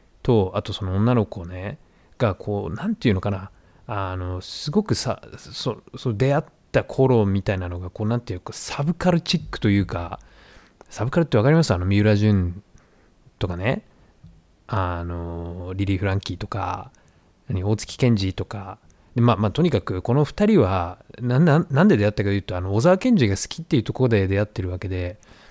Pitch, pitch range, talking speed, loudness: 105 Hz, 90-125 Hz, 335 characters per minute, -22 LUFS